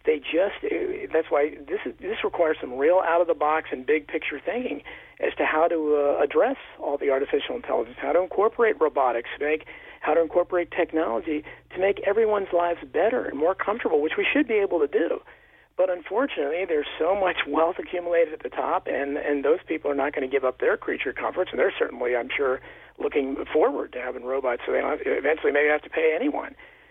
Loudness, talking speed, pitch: -25 LUFS, 215 wpm, 185 Hz